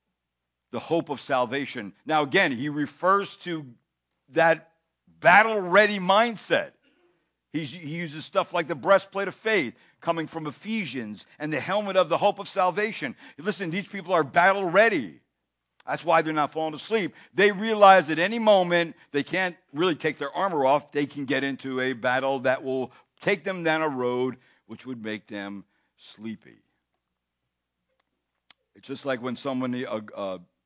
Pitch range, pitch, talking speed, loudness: 130-190 Hz, 155 Hz, 160 wpm, -24 LUFS